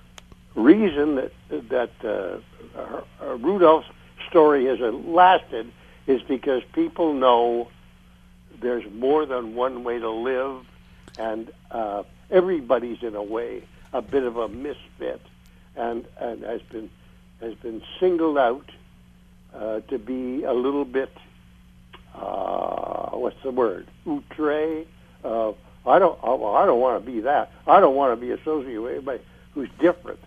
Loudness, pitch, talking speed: -23 LUFS, 120 Hz, 140 wpm